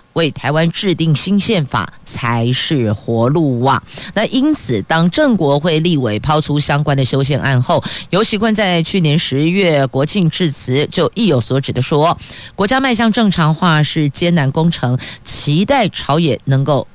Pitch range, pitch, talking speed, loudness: 135-180 Hz, 155 Hz, 240 characters per minute, -14 LUFS